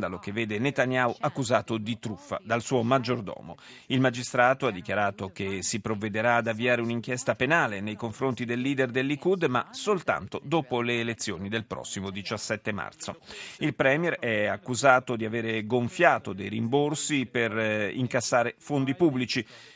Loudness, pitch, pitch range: -27 LUFS, 120 Hz, 110-130 Hz